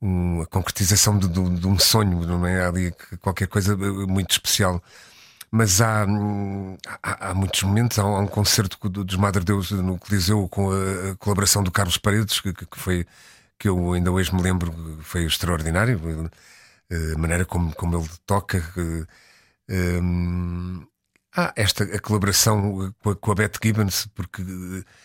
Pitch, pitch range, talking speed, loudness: 95 Hz, 90-105 Hz, 170 wpm, -22 LUFS